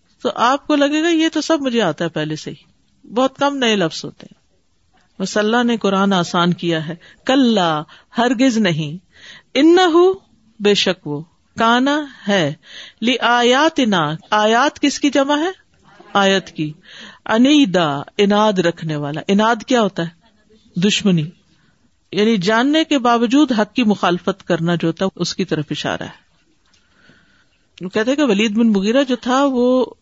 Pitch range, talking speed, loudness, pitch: 175-260 Hz, 140 wpm, -16 LUFS, 215 Hz